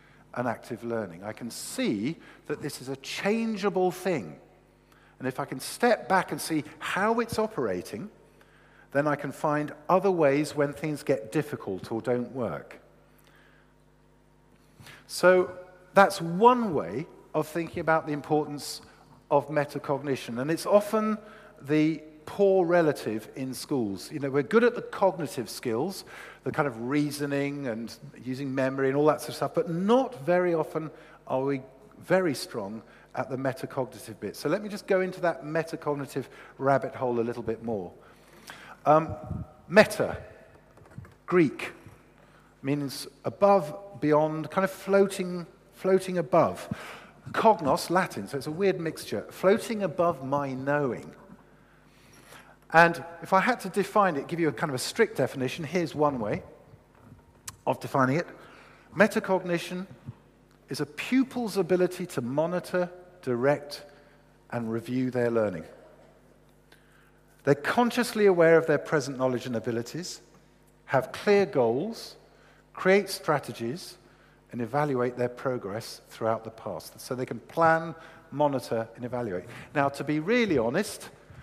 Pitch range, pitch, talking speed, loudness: 130-180 Hz, 150 Hz, 140 wpm, -28 LUFS